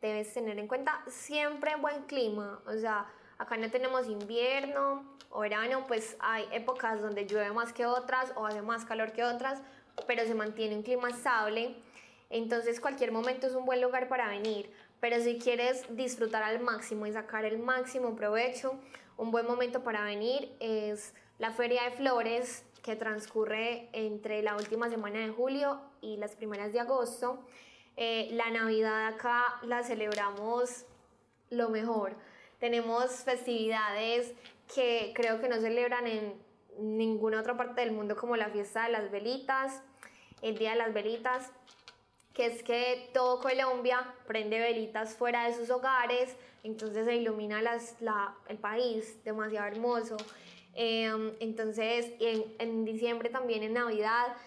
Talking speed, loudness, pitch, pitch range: 150 wpm, -33 LUFS, 235 Hz, 220-250 Hz